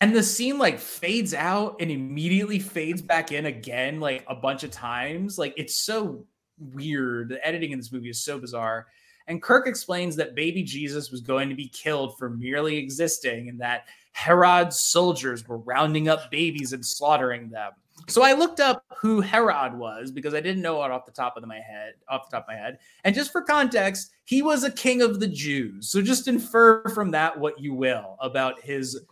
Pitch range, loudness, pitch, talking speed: 130-205 Hz, -24 LUFS, 155 Hz, 205 wpm